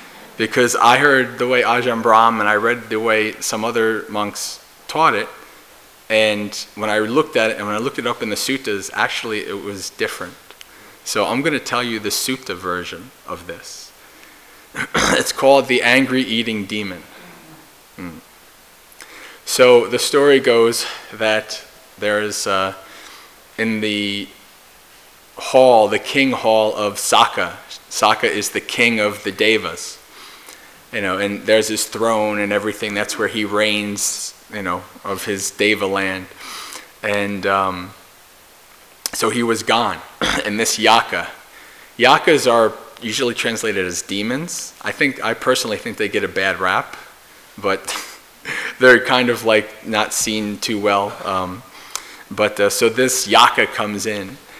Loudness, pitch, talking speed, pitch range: -17 LUFS, 110 Hz, 150 wpm, 105-115 Hz